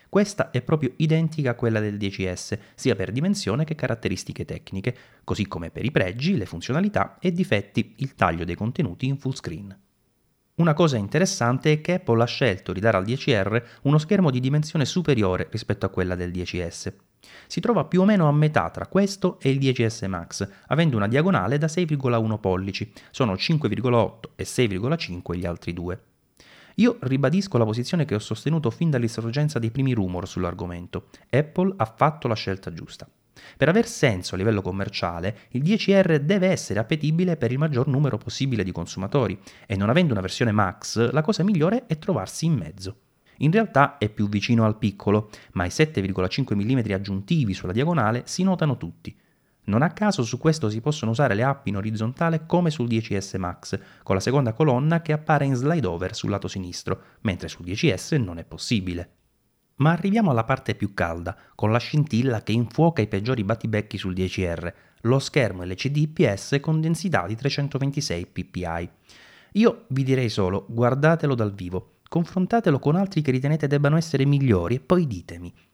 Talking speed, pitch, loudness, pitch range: 175 wpm, 120 Hz, -24 LUFS, 100-155 Hz